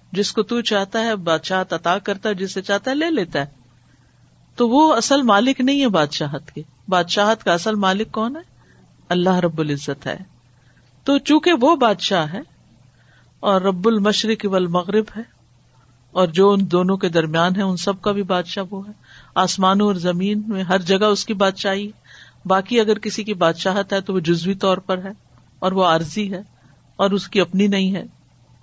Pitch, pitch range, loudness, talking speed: 195 Hz, 180-210 Hz, -19 LUFS, 190 wpm